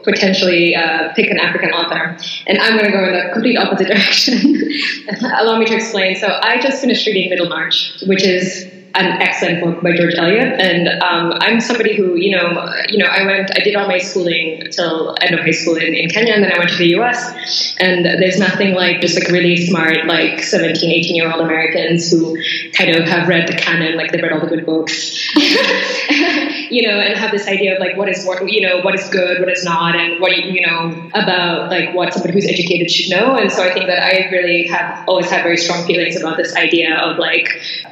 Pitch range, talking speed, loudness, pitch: 170-195 Hz, 225 wpm, -13 LUFS, 180 Hz